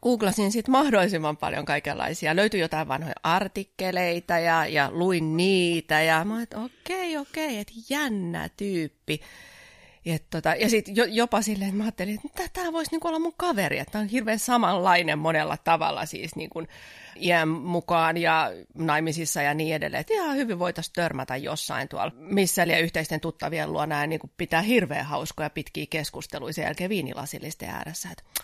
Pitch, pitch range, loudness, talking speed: 175 Hz, 160-215 Hz, -26 LUFS, 165 wpm